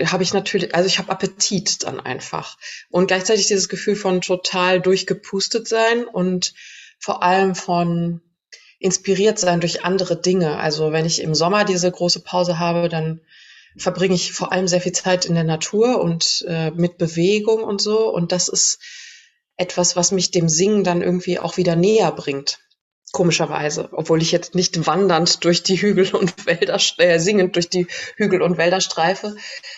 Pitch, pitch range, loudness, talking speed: 185 Hz, 175-200 Hz, -18 LUFS, 170 wpm